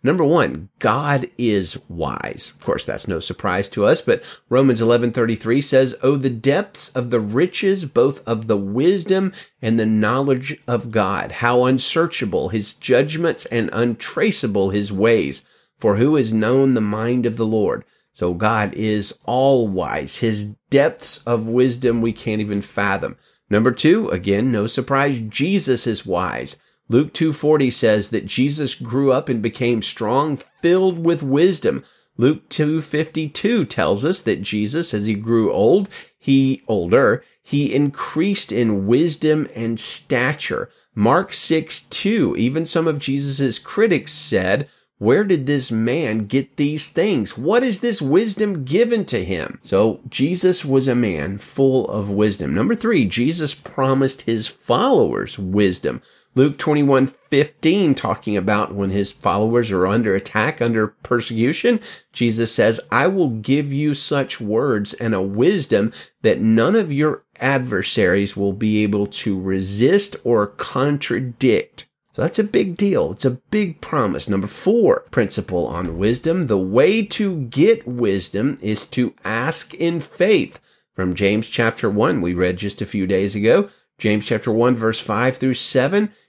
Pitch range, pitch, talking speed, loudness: 110-150 Hz, 125 Hz, 150 wpm, -19 LUFS